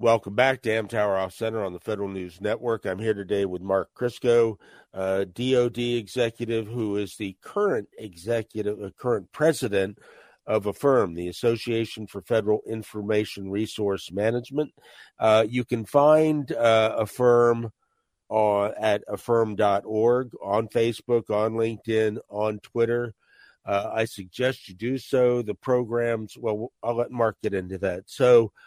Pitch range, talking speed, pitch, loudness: 105-120 Hz, 145 wpm, 110 Hz, -25 LUFS